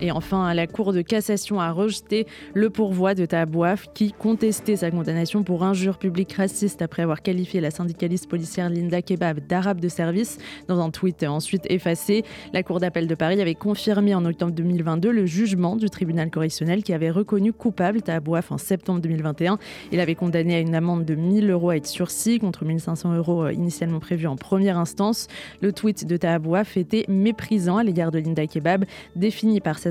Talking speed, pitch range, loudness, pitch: 190 wpm, 170-200 Hz, -23 LUFS, 180 Hz